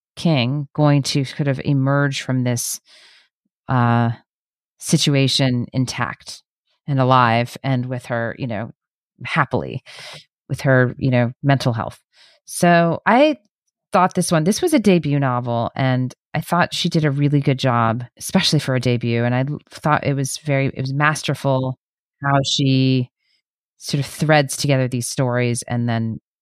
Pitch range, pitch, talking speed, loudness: 125-150 Hz, 135 Hz, 150 wpm, -19 LUFS